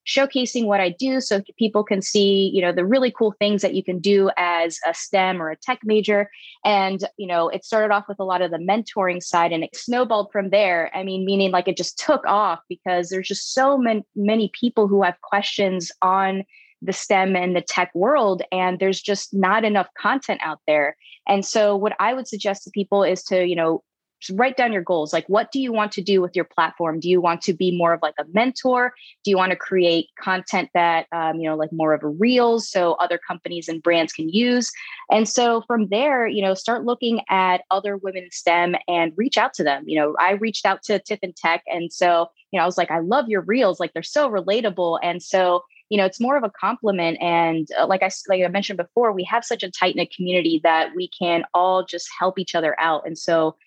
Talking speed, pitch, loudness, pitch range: 235 wpm, 190 Hz, -21 LUFS, 175-210 Hz